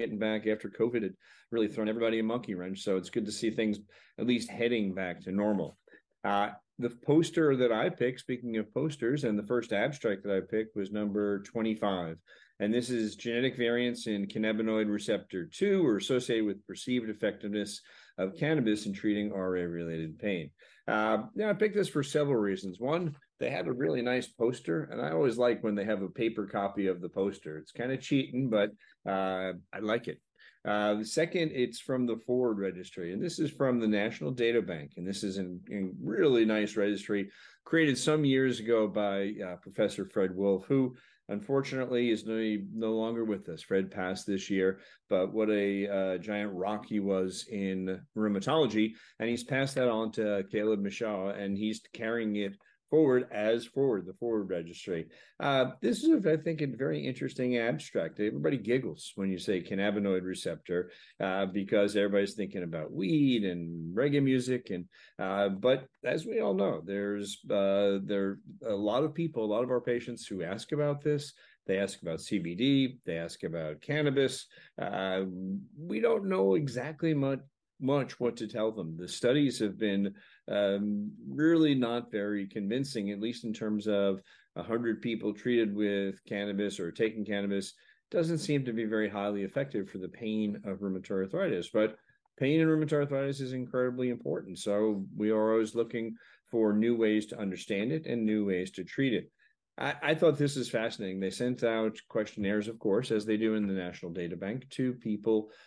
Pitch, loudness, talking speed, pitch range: 110 Hz, -32 LUFS, 185 wpm, 100-125 Hz